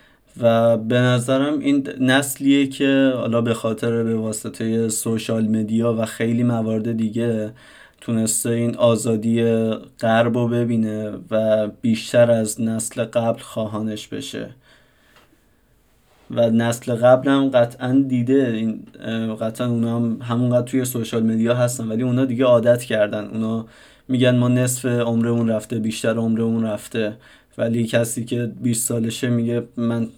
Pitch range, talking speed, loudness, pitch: 110-120 Hz, 130 wpm, -20 LUFS, 115 Hz